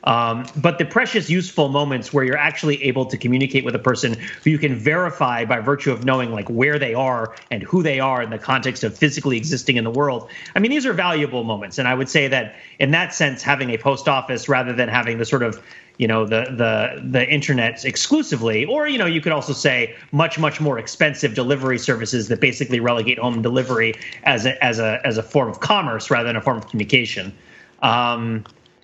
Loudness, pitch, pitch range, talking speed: -19 LUFS, 130 Hz, 115-145 Hz, 220 wpm